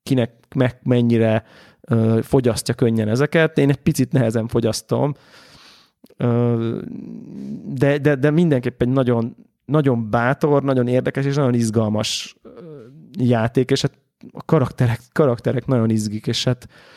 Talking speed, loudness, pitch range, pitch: 130 wpm, -19 LUFS, 115-145 Hz, 125 Hz